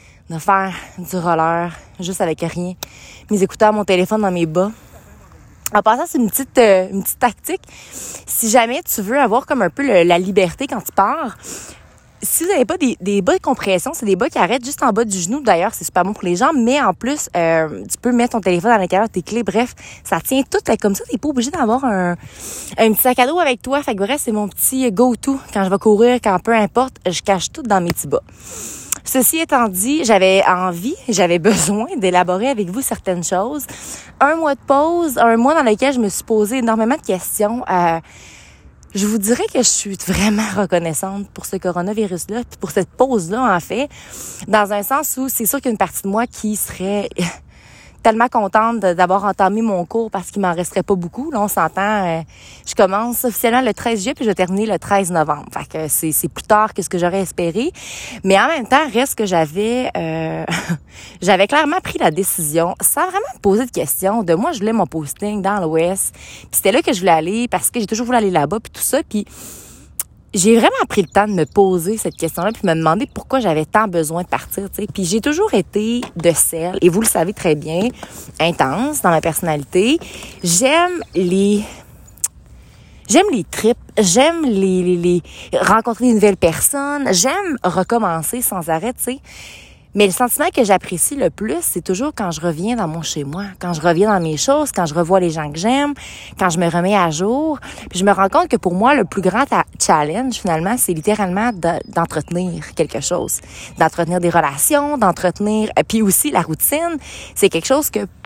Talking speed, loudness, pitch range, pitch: 210 wpm, -16 LUFS, 180-245 Hz, 205 Hz